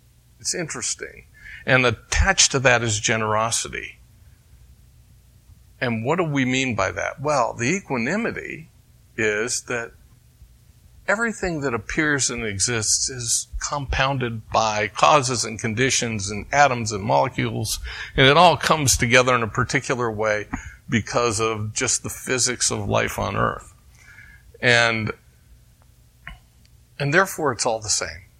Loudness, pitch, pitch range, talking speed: -21 LUFS, 120 Hz, 110-135 Hz, 125 wpm